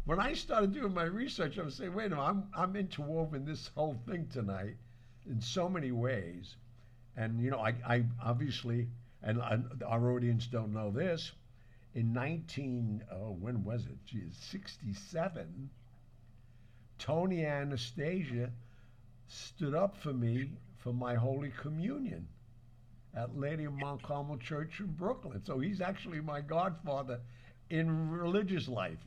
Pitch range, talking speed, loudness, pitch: 120-160 Hz, 140 wpm, -37 LUFS, 125 Hz